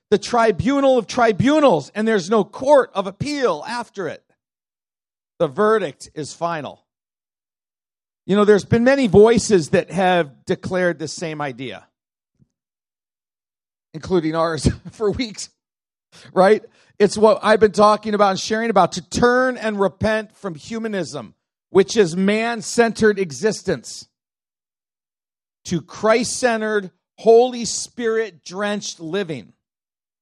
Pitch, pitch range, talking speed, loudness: 205 Hz, 175-225 Hz, 115 wpm, -18 LUFS